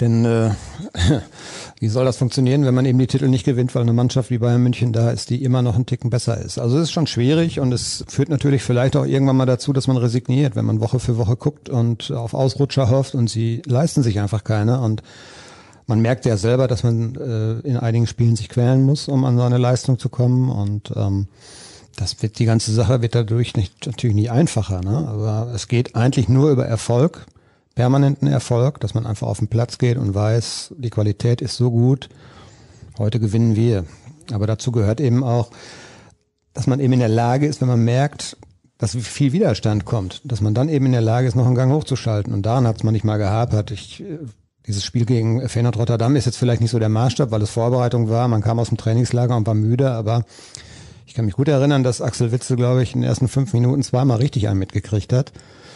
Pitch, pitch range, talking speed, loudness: 120 Hz, 115-130 Hz, 225 wpm, -19 LUFS